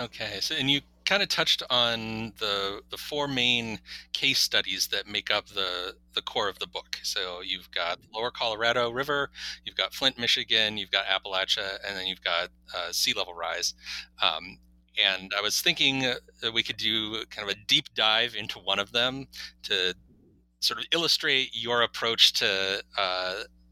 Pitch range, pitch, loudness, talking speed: 95-130 Hz, 110 Hz, -26 LUFS, 175 wpm